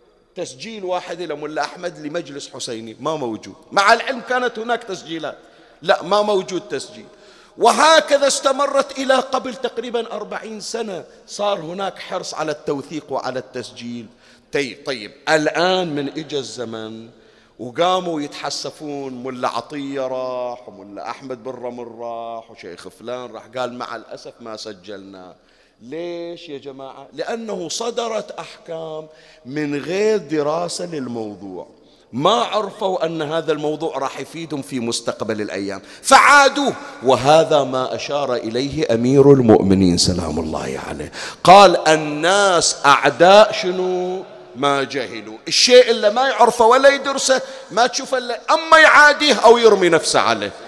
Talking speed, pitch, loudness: 125 wpm, 155 Hz, -16 LUFS